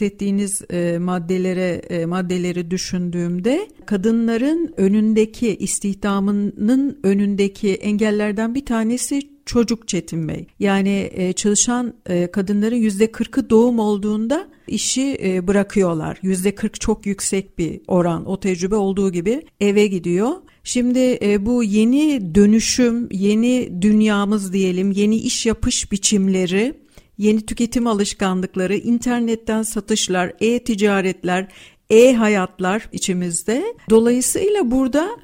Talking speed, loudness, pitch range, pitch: 105 wpm, -18 LUFS, 190-235 Hz, 210 Hz